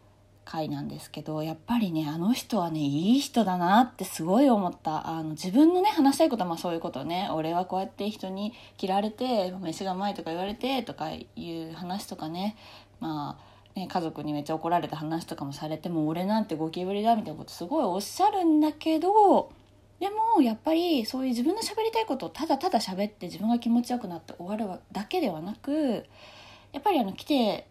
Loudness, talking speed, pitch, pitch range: -28 LUFS, 420 characters per minute, 200 Hz, 165-270 Hz